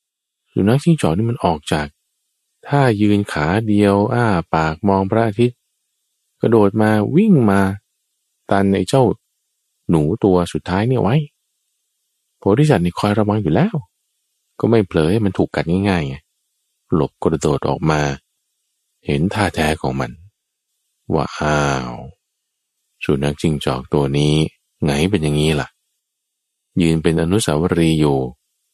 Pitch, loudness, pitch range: 95 Hz, -17 LUFS, 75-105 Hz